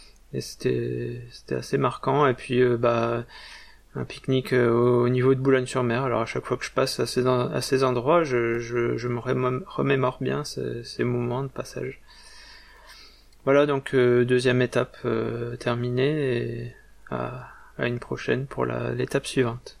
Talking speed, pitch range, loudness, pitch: 175 wpm, 120-130 Hz, -25 LUFS, 125 Hz